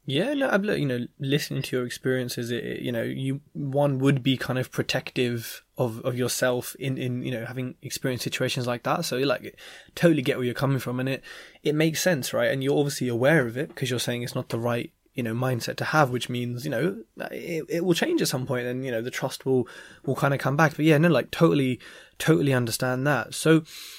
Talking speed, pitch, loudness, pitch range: 240 wpm, 135 Hz, -26 LUFS, 125-150 Hz